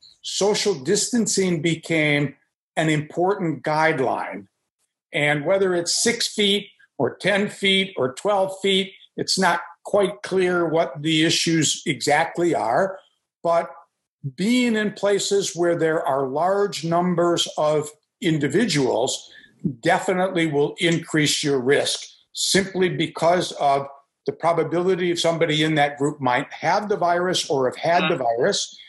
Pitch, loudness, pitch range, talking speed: 170 Hz, -21 LUFS, 155-190 Hz, 125 wpm